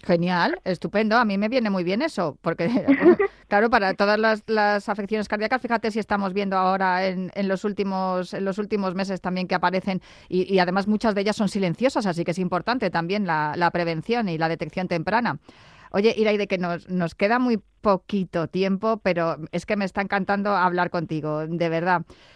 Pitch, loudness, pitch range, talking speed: 190 Hz, -23 LUFS, 180-210 Hz, 195 wpm